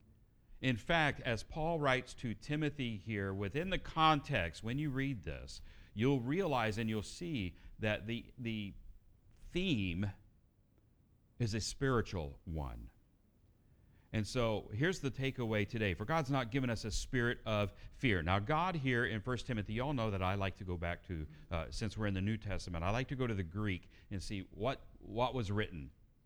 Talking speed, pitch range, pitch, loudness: 180 wpm, 95-125 Hz, 110 Hz, -38 LUFS